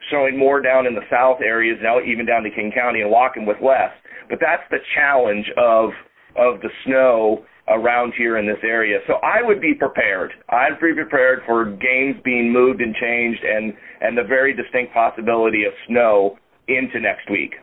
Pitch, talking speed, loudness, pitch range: 120 Hz, 185 wpm, -18 LUFS, 110-130 Hz